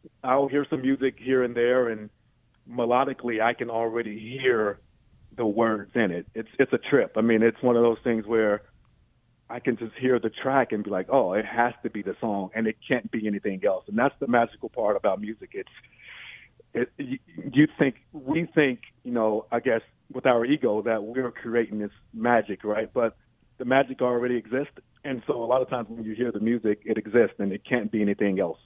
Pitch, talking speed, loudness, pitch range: 115 Hz, 210 wpm, -26 LUFS, 110-125 Hz